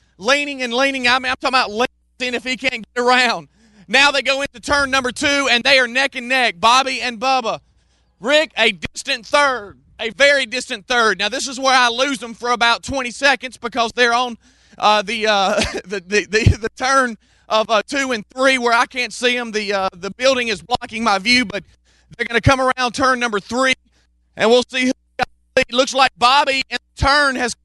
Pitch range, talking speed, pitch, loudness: 225-265 Hz, 215 wpm, 245 Hz, -17 LUFS